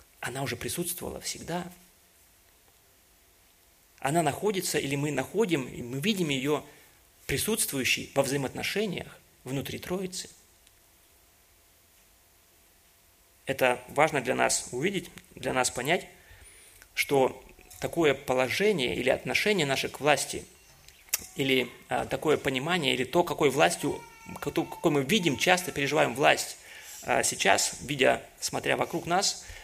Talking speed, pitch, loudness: 110 wpm, 130 Hz, -28 LUFS